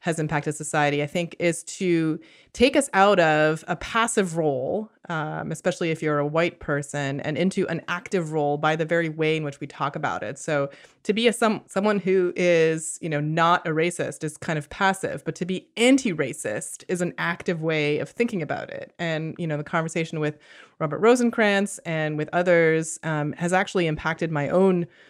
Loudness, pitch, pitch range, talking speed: -24 LUFS, 165 Hz, 155-185 Hz, 195 wpm